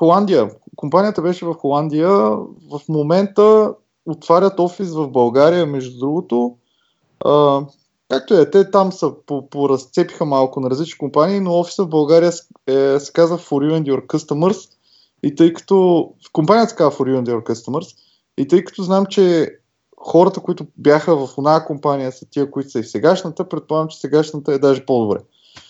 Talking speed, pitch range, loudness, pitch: 170 wpm, 140-175 Hz, -16 LUFS, 155 Hz